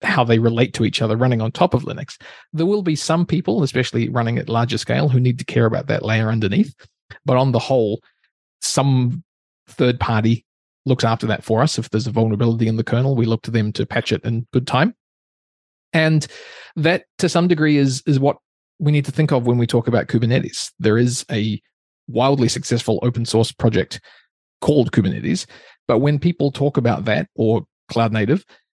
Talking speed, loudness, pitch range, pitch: 200 wpm, -19 LUFS, 115-145 Hz, 120 Hz